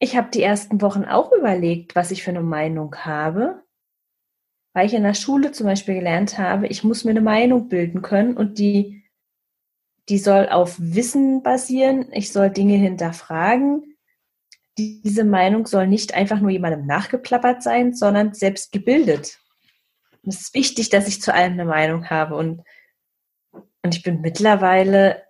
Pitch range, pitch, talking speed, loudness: 180-230 Hz, 200 Hz, 160 wpm, -19 LUFS